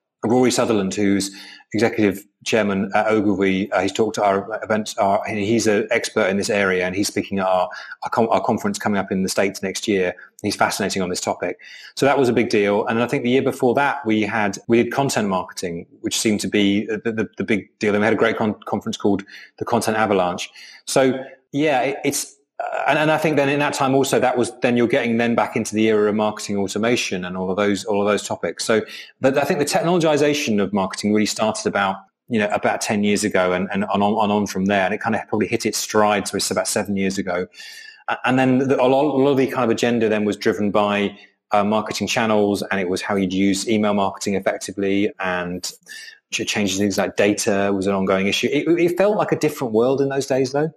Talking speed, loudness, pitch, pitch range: 235 wpm, -20 LUFS, 105 Hz, 100-130 Hz